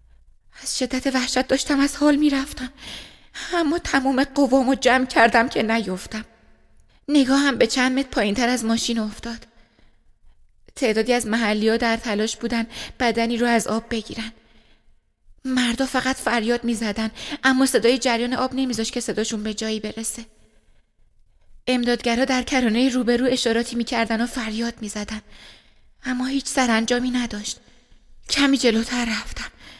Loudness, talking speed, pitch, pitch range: -21 LUFS, 140 wpm, 240 Hz, 225-260 Hz